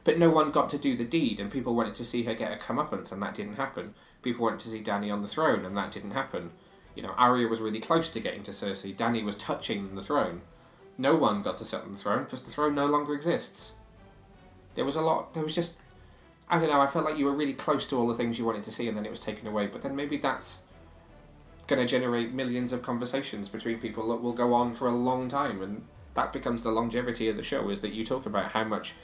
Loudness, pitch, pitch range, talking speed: -30 LUFS, 120 Hz, 110-140 Hz, 265 wpm